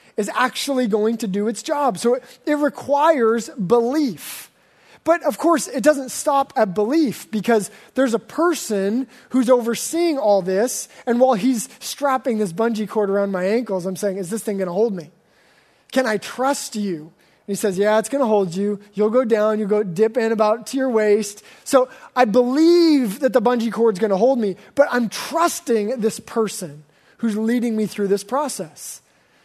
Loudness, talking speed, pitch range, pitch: -20 LUFS, 185 wpm, 210-260 Hz, 230 Hz